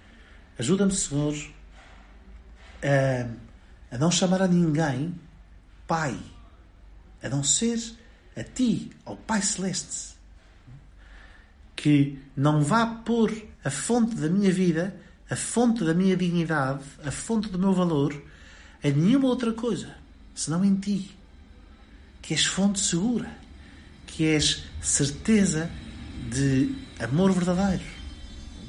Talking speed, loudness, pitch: 110 wpm, -25 LUFS, 145 Hz